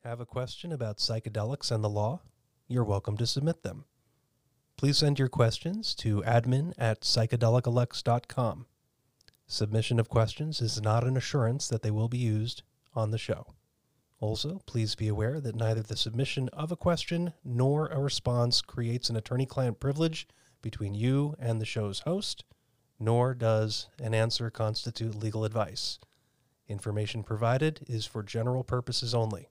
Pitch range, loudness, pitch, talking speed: 110-130 Hz, -30 LUFS, 120 Hz, 155 wpm